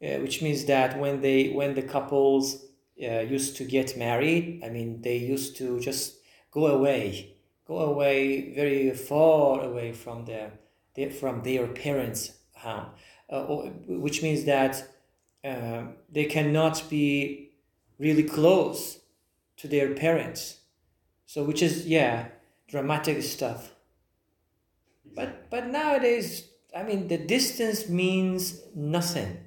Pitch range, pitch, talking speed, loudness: 115-155 Hz, 135 Hz, 130 wpm, -27 LUFS